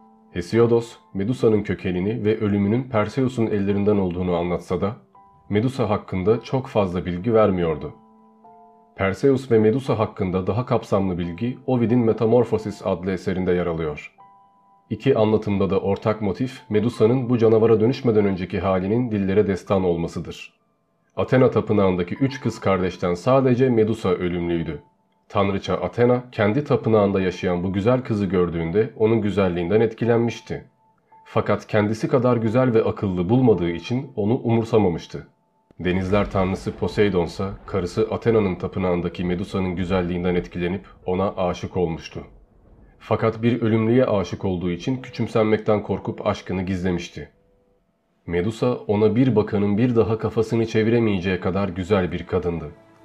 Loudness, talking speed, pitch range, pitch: -21 LUFS, 120 wpm, 95-115 Hz, 105 Hz